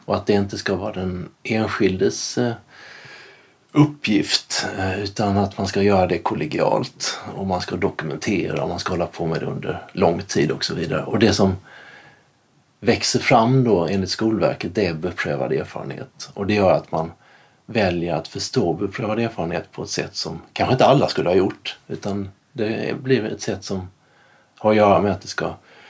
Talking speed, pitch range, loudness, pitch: 180 wpm, 90-110 Hz, -21 LUFS, 100 Hz